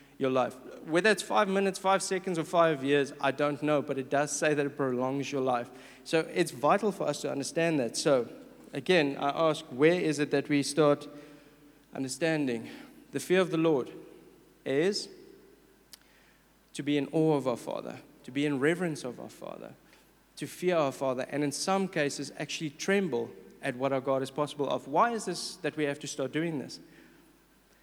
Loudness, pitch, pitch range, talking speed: -30 LUFS, 145 Hz, 140-165 Hz, 195 wpm